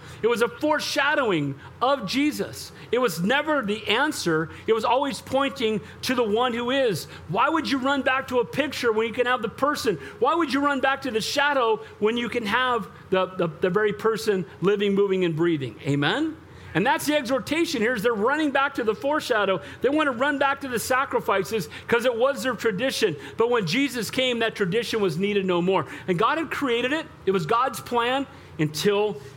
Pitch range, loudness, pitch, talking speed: 205-275 Hz, -24 LUFS, 240 Hz, 205 wpm